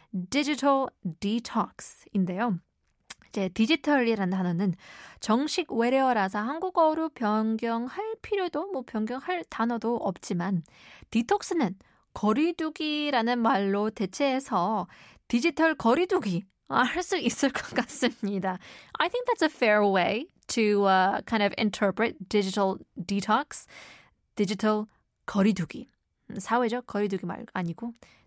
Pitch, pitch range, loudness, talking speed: 225 Hz, 200-280 Hz, -27 LUFS, 310 characters per minute